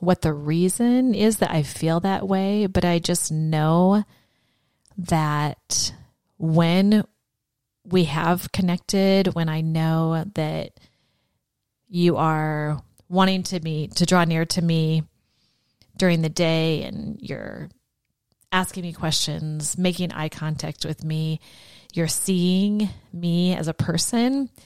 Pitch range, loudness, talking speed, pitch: 155-185 Hz, -22 LUFS, 125 wpm, 170 Hz